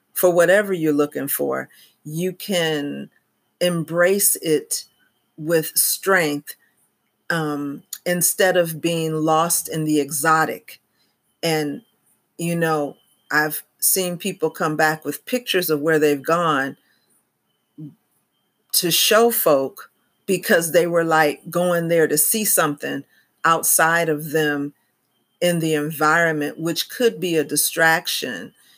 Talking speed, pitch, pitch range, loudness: 115 wpm, 160 Hz, 155-175 Hz, -19 LUFS